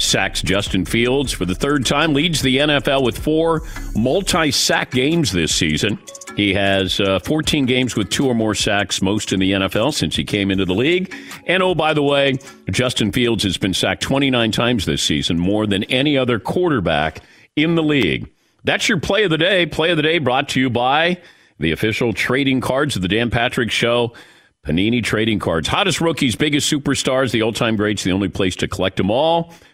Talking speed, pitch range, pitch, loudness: 200 wpm, 100-145 Hz, 120 Hz, -17 LUFS